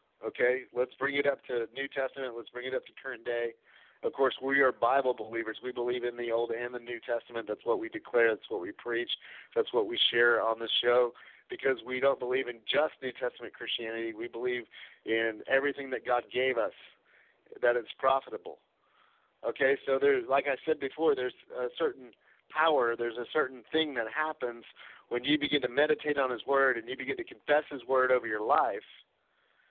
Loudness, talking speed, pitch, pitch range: -31 LUFS, 200 wpm, 125 Hz, 120-140 Hz